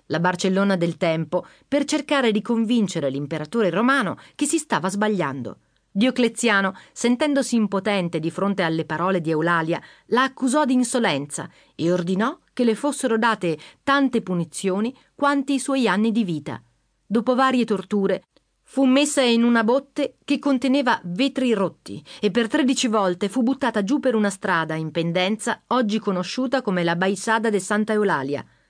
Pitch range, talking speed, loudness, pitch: 180-255 Hz, 155 wpm, -22 LUFS, 220 Hz